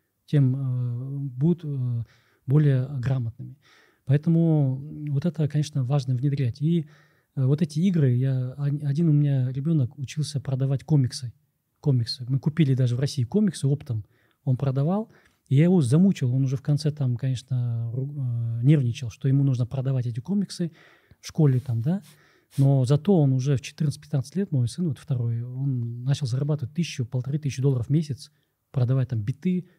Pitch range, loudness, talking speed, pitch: 125-150 Hz, -25 LUFS, 160 wpm, 135 Hz